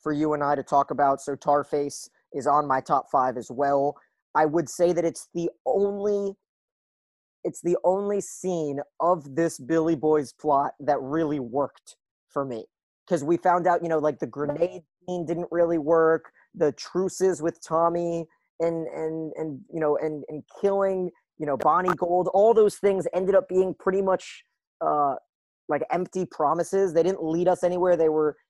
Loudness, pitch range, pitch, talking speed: -25 LUFS, 150-180 Hz, 165 Hz, 180 wpm